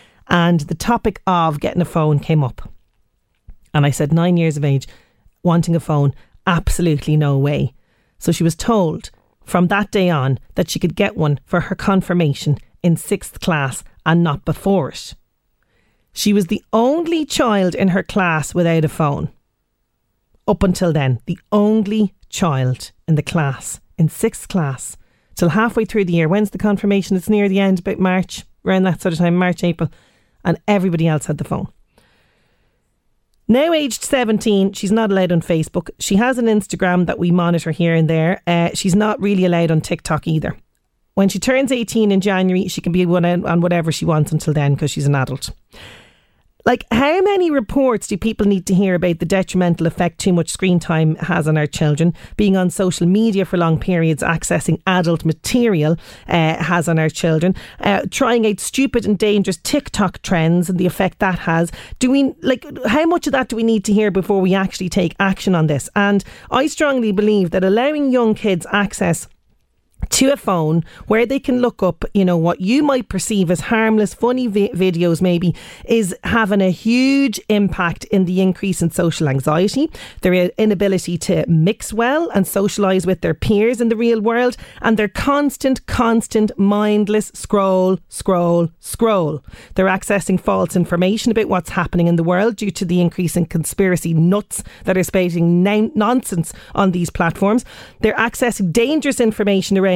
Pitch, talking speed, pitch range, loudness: 185 Hz, 180 wpm, 170-210 Hz, -17 LUFS